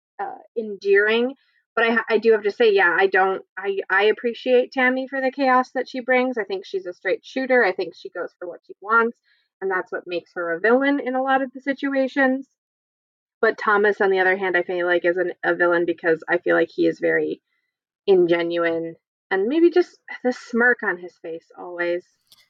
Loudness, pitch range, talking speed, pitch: -21 LUFS, 180-260 Hz, 210 wpm, 225 Hz